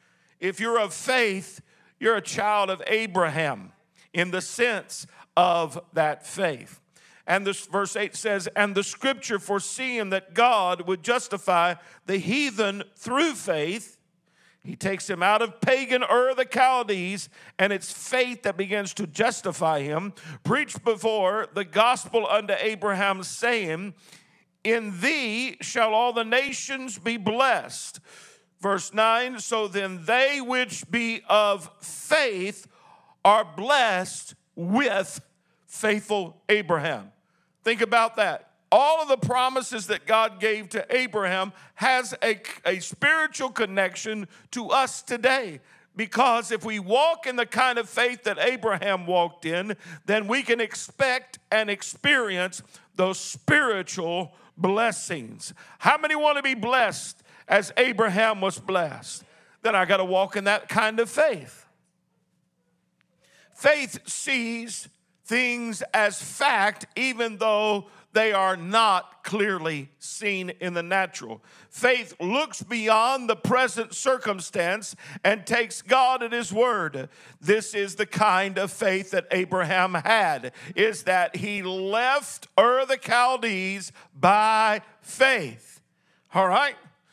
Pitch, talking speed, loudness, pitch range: 210 Hz, 130 wpm, -24 LUFS, 185-235 Hz